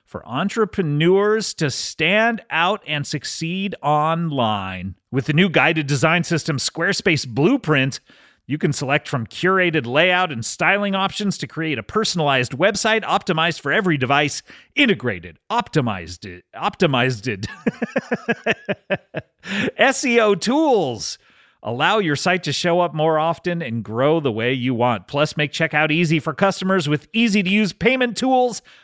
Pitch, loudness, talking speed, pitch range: 165 Hz, -19 LUFS, 135 wpm, 145-200 Hz